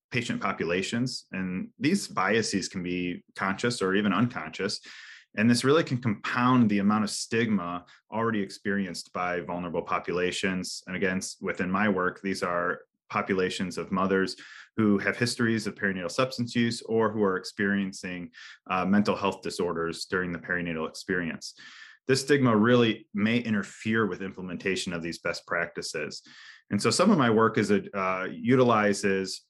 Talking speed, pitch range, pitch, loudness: 155 wpm, 95-115 Hz, 100 Hz, -27 LUFS